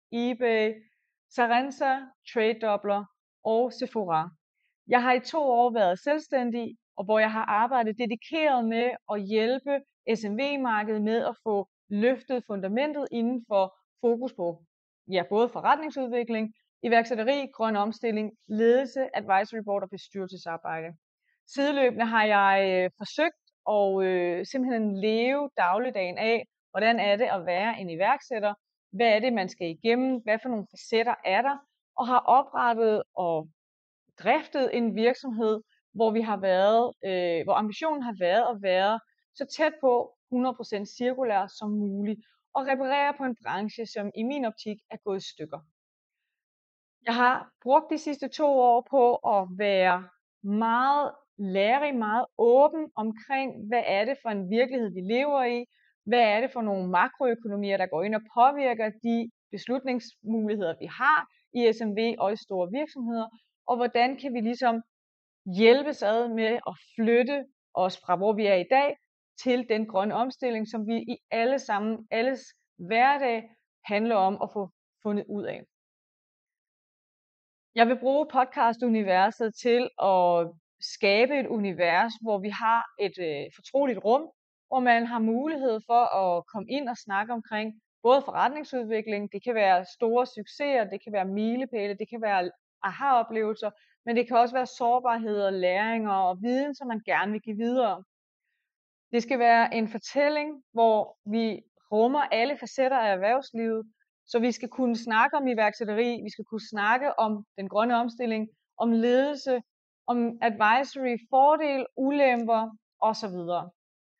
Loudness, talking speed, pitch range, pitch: -27 LUFS, 150 wpm, 205-255 Hz, 230 Hz